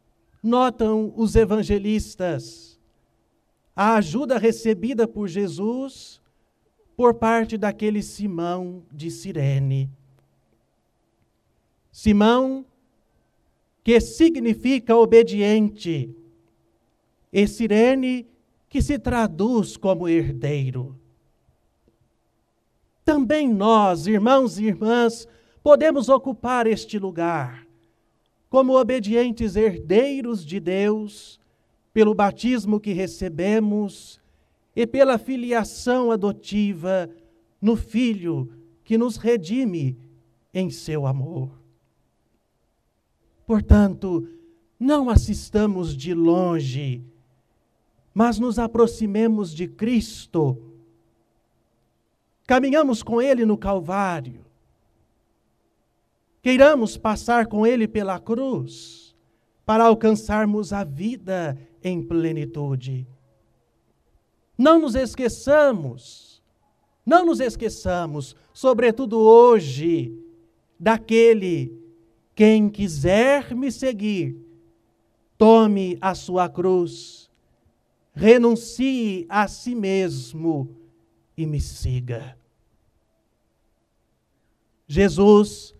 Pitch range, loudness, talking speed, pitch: 150-230 Hz, -20 LUFS, 75 wpm, 205 Hz